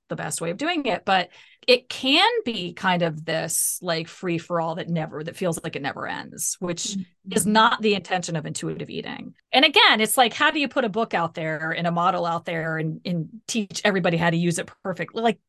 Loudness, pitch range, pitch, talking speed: -23 LUFS, 170-220 Hz, 180 Hz, 230 wpm